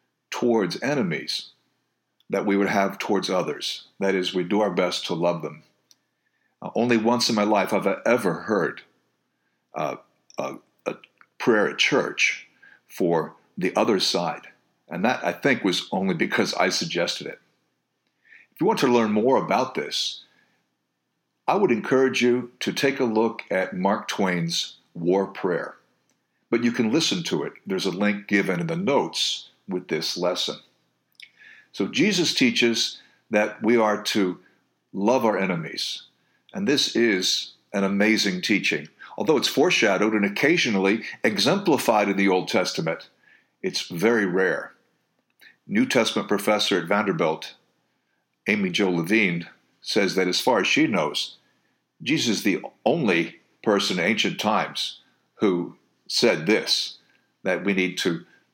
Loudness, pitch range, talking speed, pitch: -23 LUFS, 95-120 Hz, 145 wpm, 105 Hz